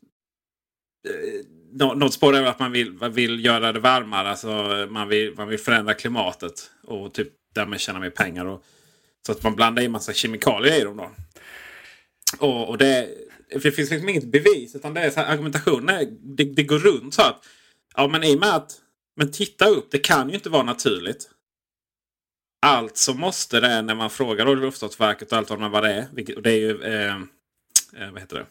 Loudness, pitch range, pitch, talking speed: -21 LUFS, 110-150 Hz, 130 Hz, 190 wpm